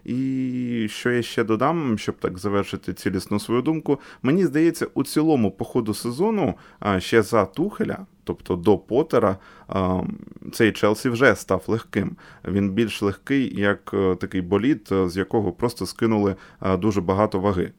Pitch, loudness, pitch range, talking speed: 105 Hz, -23 LUFS, 95-120 Hz, 140 wpm